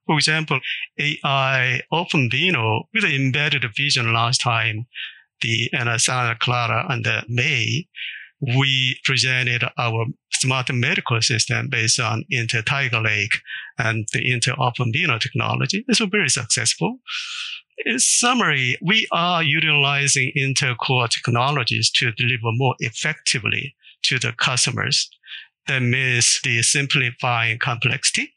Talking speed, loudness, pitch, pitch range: 115 wpm, -19 LUFS, 130 Hz, 120-150 Hz